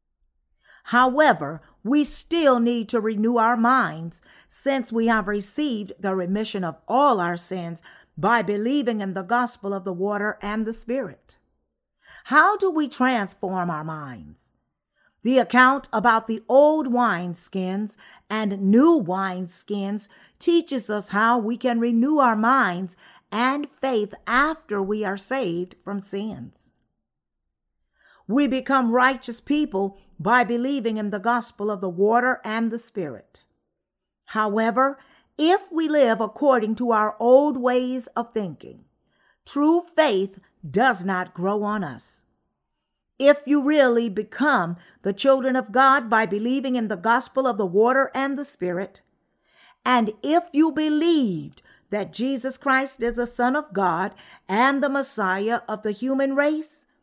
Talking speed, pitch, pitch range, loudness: 140 wpm, 235 Hz, 200-265 Hz, -22 LUFS